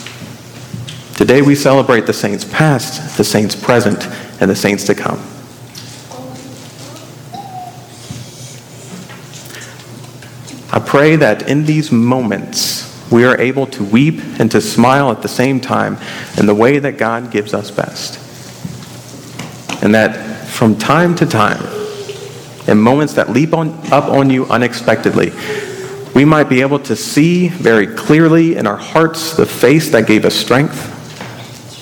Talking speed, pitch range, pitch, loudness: 135 wpm, 115-145 Hz, 130 Hz, -12 LUFS